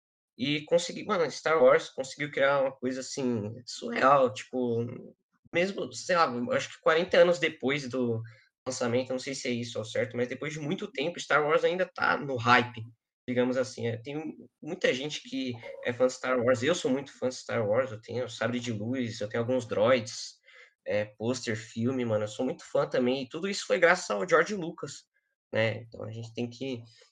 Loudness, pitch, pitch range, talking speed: -29 LUFS, 125 Hz, 120-140 Hz, 200 wpm